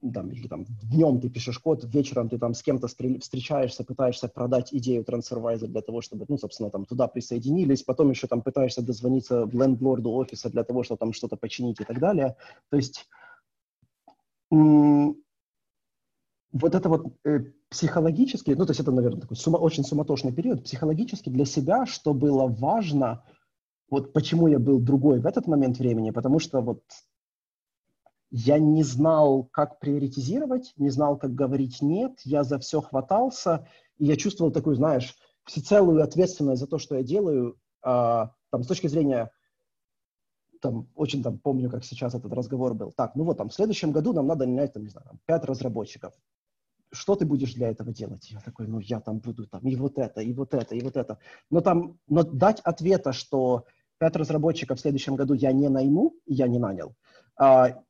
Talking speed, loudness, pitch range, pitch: 175 wpm, -25 LUFS, 125-155 Hz, 135 Hz